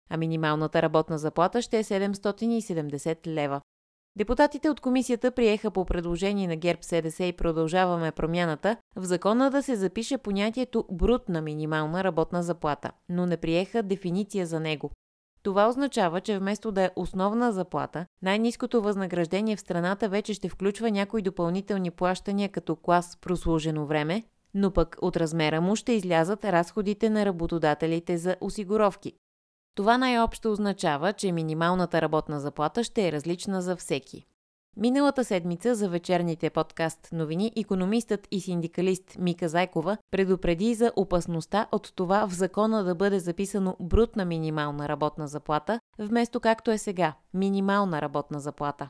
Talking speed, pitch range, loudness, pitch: 140 wpm, 165-210 Hz, -27 LUFS, 185 Hz